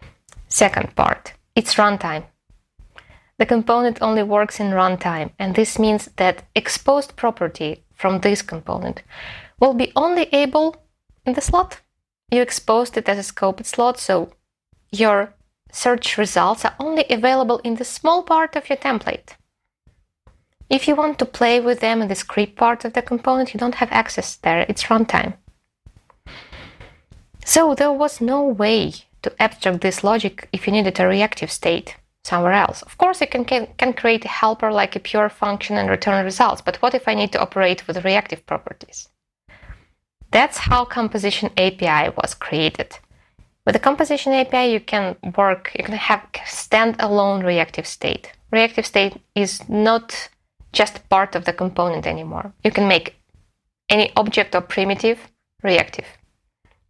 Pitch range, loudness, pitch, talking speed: 195-250 Hz, -19 LUFS, 220 Hz, 155 wpm